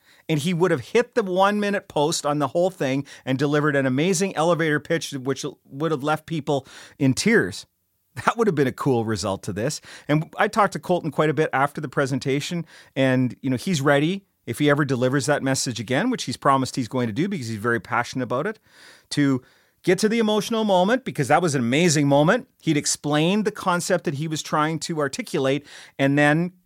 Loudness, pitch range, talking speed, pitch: -22 LUFS, 135-175 Hz, 215 wpm, 150 Hz